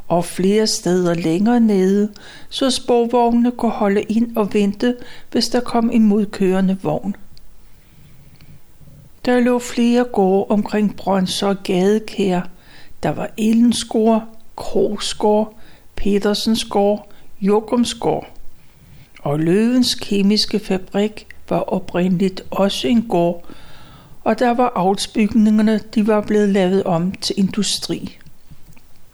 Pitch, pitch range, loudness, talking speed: 210 Hz, 195-230 Hz, -18 LUFS, 105 wpm